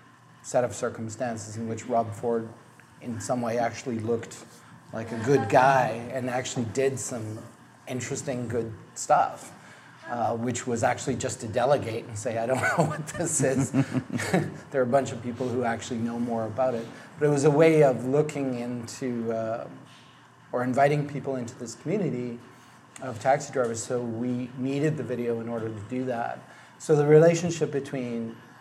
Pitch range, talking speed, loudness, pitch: 115-135 Hz, 170 wpm, -27 LUFS, 125 Hz